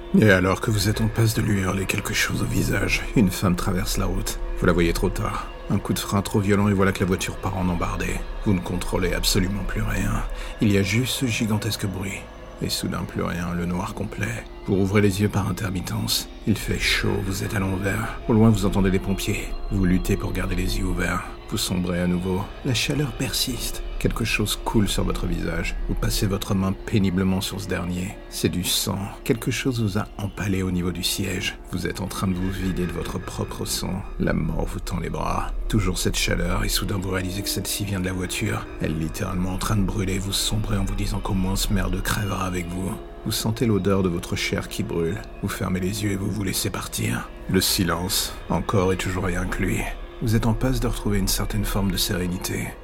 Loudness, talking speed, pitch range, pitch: -24 LUFS, 230 wpm, 90-105 Hz, 100 Hz